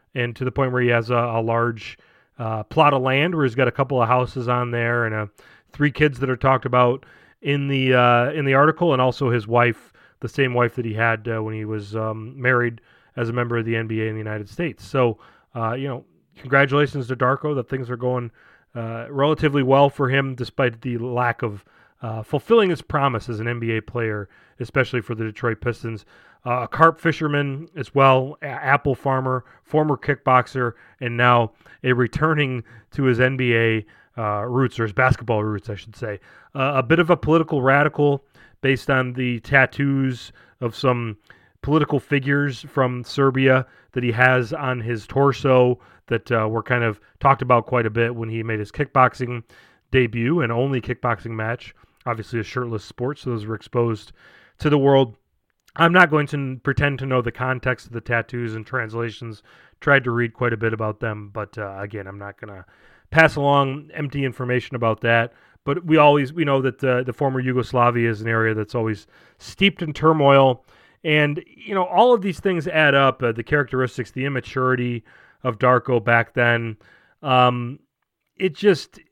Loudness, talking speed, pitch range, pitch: -20 LUFS, 190 wpm, 115-140 Hz, 125 Hz